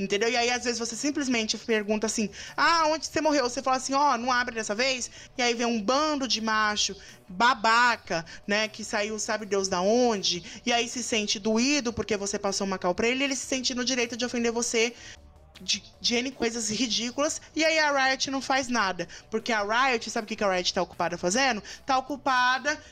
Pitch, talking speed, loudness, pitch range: 235 Hz, 215 wpm, -26 LUFS, 215-260 Hz